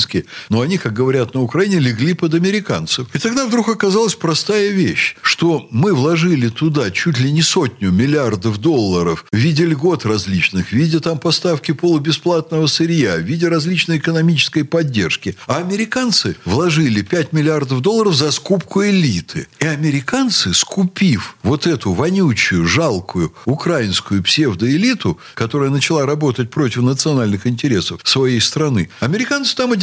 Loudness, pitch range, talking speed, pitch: -15 LUFS, 130-175 Hz, 140 wpm, 155 Hz